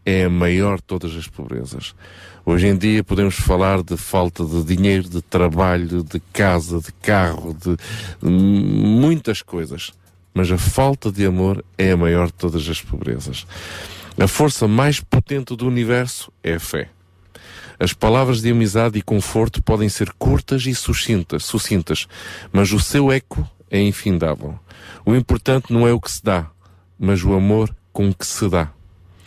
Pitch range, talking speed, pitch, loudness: 90-110 Hz, 160 wpm, 95 Hz, -19 LUFS